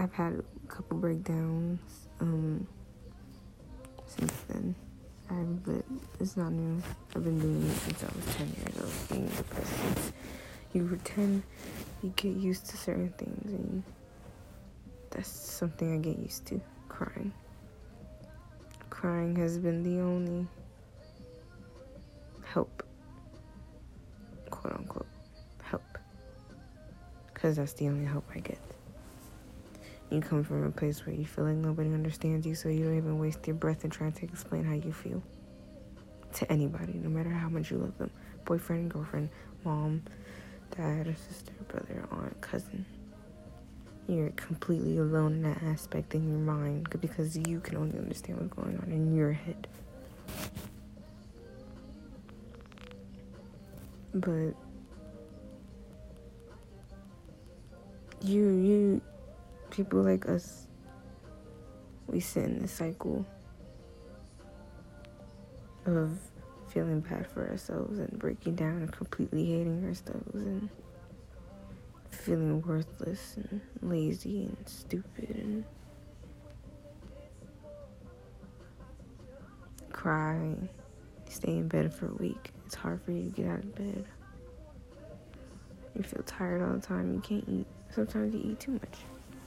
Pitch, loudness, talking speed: 155 Hz, -35 LUFS, 120 wpm